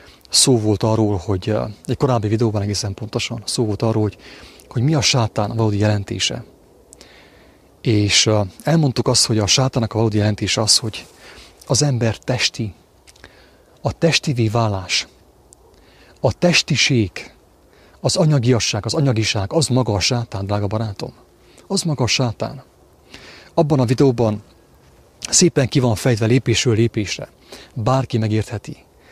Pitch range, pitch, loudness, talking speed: 105-130 Hz, 115 Hz, -18 LUFS, 130 wpm